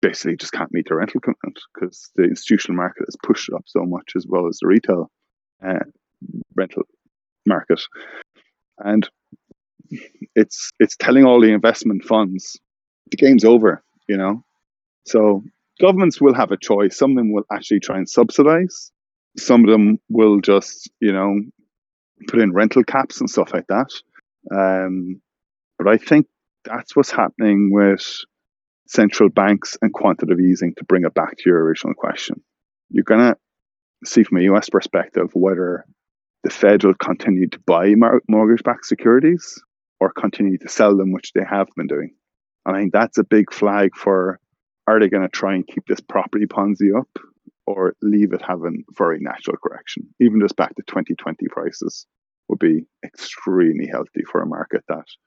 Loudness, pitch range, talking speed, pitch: -17 LUFS, 95-110 Hz, 170 wpm, 105 Hz